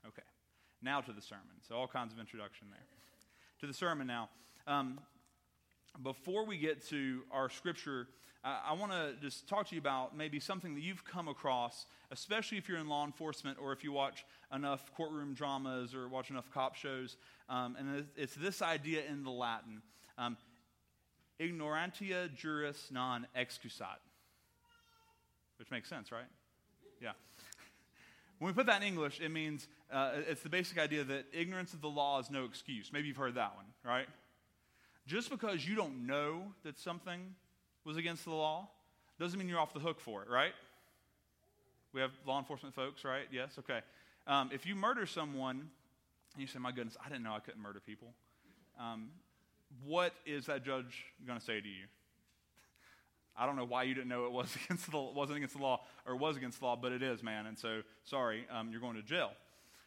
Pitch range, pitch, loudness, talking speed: 125-155 Hz, 140 Hz, -41 LUFS, 190 wpm